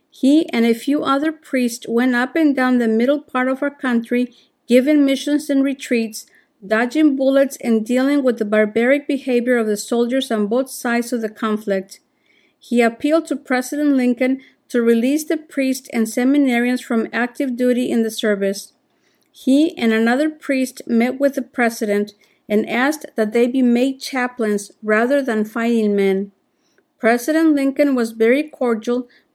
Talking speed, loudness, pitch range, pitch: 160 wpm, -18 LUFS, 230-285 Hz, 255 Hz